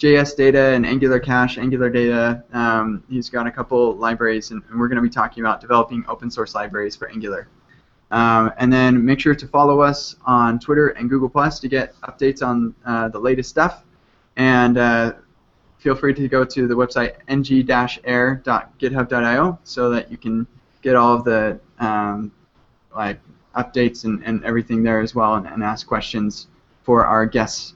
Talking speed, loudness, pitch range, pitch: 175 wpm, -18 LUFS, 115-130 Hz, 120 Hz